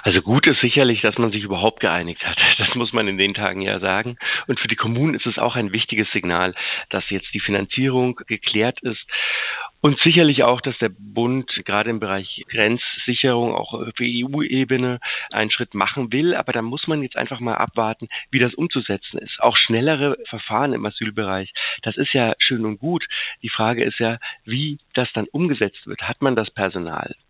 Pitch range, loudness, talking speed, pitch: 105-130 Hz, -20 LUFS, 190 wpm, 115 Hz